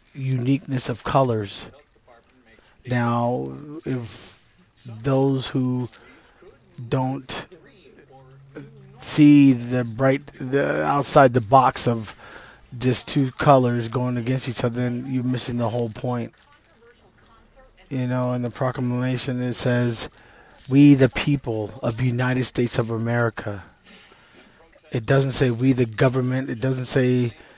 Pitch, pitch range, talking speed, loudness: 125 Hz, 120-135 Hz, 115 wpm, -21 LUFS